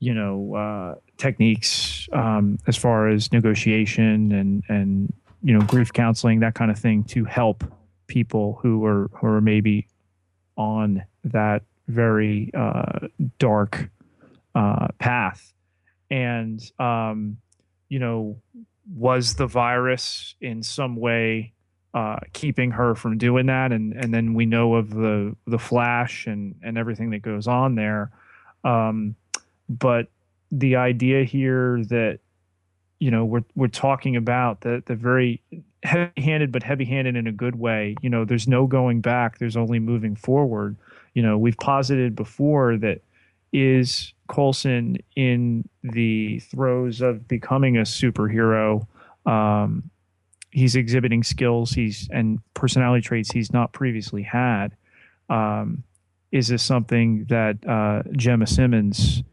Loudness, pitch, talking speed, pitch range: -22 LUFS, 115 Hz, 135 wpm, 105-125 Hz